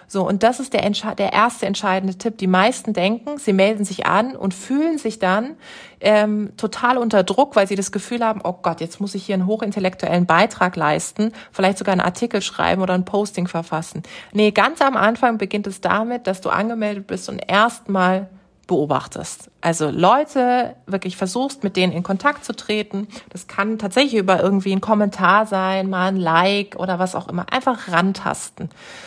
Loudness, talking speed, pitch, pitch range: -19 LUFS, 185 wpm, 200 Hz, 185-220 Hz